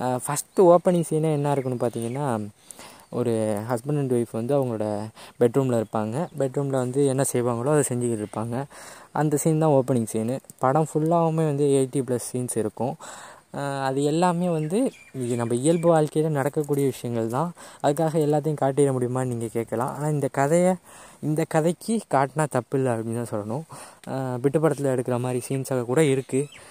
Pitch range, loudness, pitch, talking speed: 120-155 Hz, -24 LUFS, 135 Hz, 145 wpm